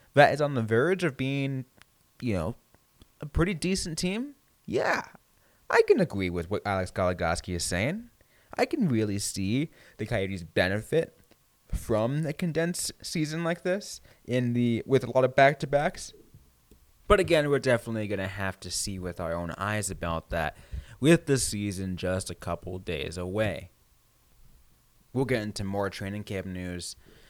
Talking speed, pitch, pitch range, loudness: 165 wpm, 110 Hz, 95-145 Hz, -28 LUFS